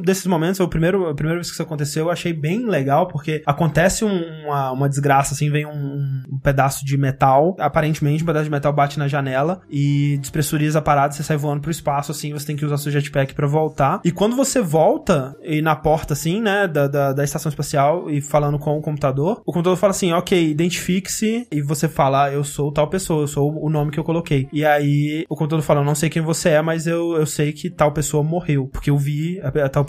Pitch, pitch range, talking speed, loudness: 150 Hz, 145-165 Hz, 235 wpm, -19 LUFS